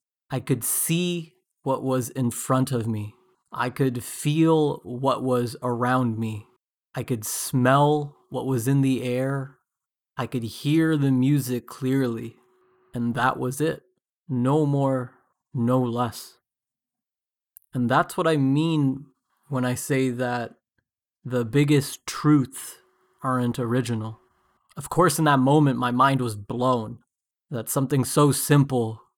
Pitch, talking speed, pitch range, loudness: 130 Hz, 135 wpm, 125-145 Hz, -24 LUFS